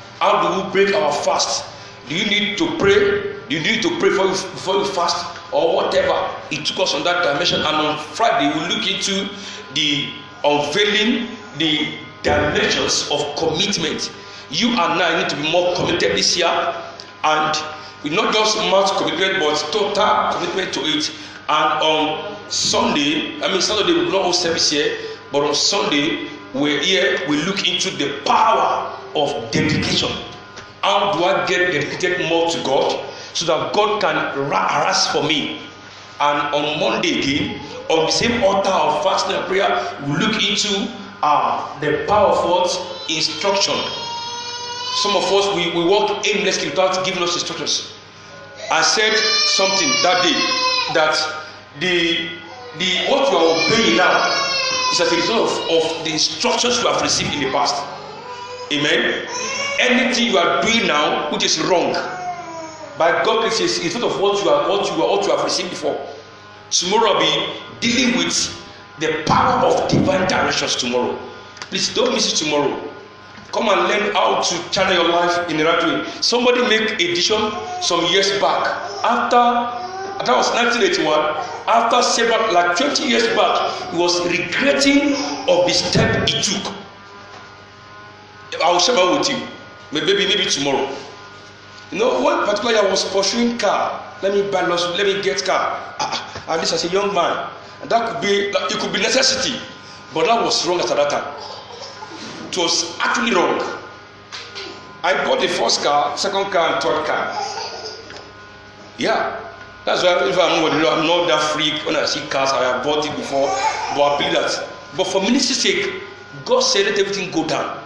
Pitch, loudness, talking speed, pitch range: 185 Hz, -17 LUFS, 170 wpm, 155-230 Hz